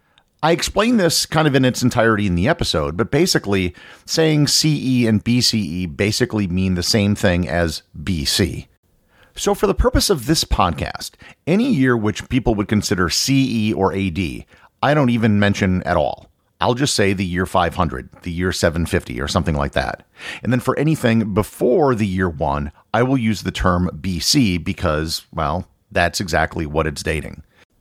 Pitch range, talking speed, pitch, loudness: 90-125 Hz, 175 wpm, 100 Hz, -18 LUFS